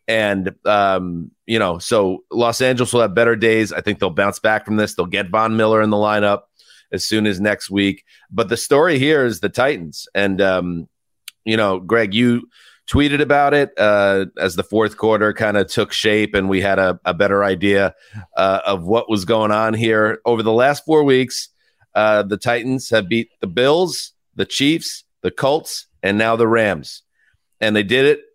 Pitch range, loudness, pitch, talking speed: 100-115 Hz, -17 LUFS, 110 Hz, 195 wpm